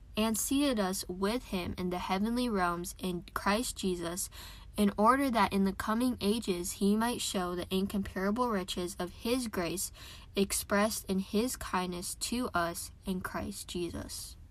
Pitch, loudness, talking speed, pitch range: 195 Hz, -33 LUFS, 155 wpm, 180-220 Hz